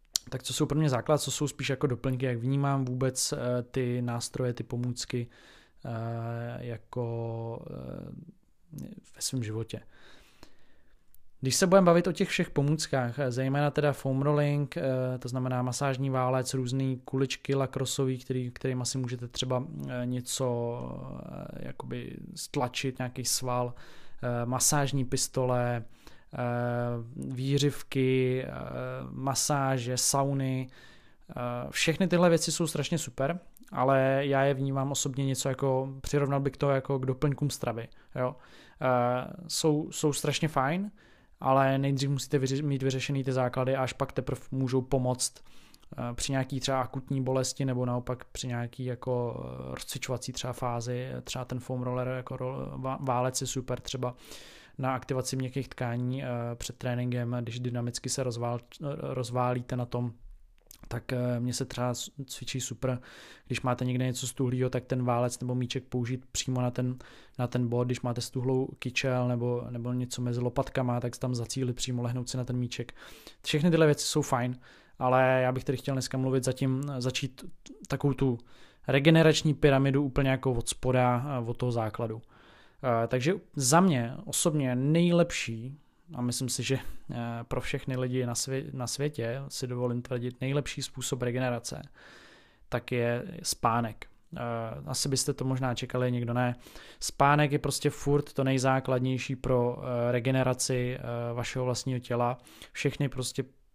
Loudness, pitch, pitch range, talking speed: -30 LUFS, 130 Hz, 125-135 Hz, 140 wpm